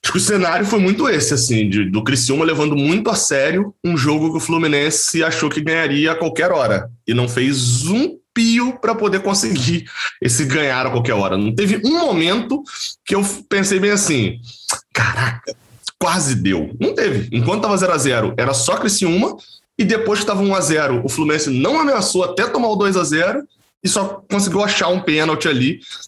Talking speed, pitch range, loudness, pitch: 185 wpm, 135-200 Hz, -17 LUFS, 165 Hz